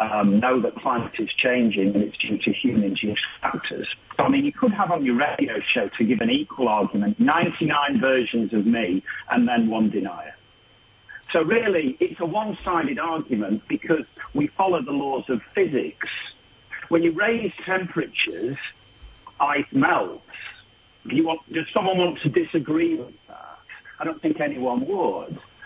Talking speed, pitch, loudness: 155 wpm, 170 Hz, -23 LUFS